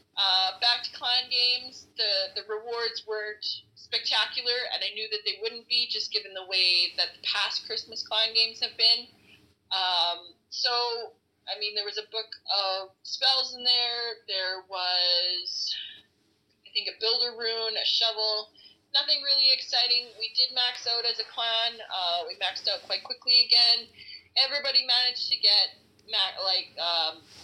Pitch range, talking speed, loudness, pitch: 190-245 Hz, 160 wpm, -25 LUFS, 225 Hz